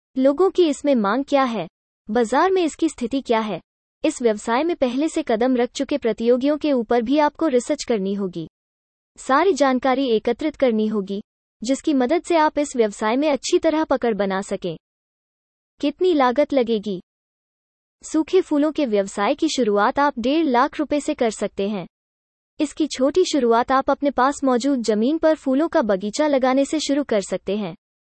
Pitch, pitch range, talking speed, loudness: 265 Hz, 220-300 Hz, 170 wpm, -20 LUFS